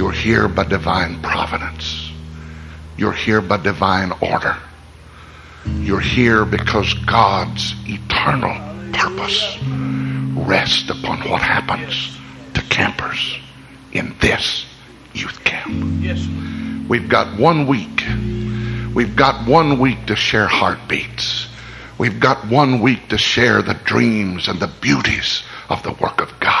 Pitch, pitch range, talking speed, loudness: 100 Hz, 80-115 Hz, 120 wpm, -17 LUFS